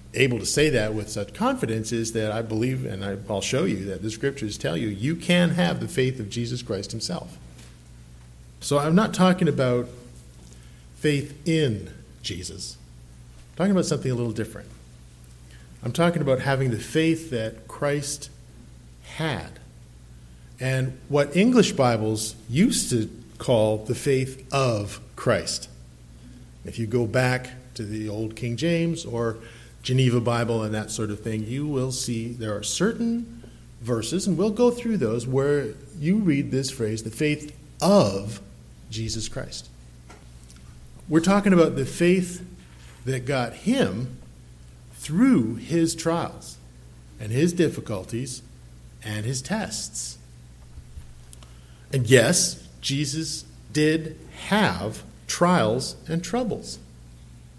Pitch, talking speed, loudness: 115 Hz, 135 wpm, -24 LUFS